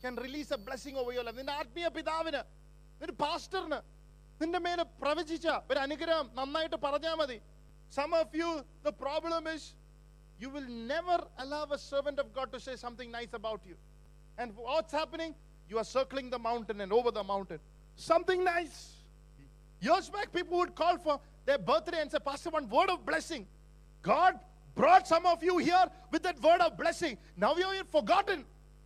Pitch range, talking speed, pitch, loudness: 235-330 Hz, 165 wpm, 290 Hz, -33 LUFS